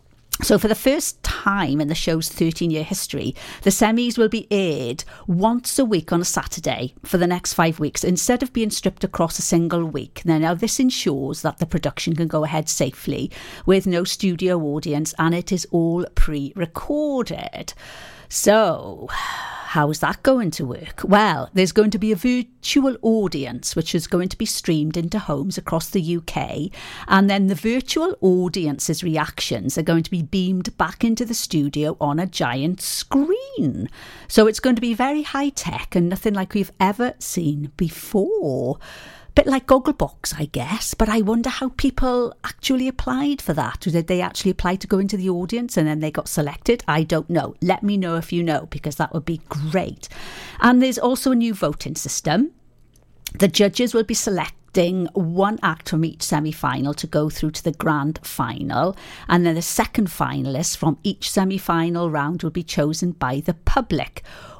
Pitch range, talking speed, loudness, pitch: 160-220 Hz, 185 wpm, -21 LUFS, 180 Hz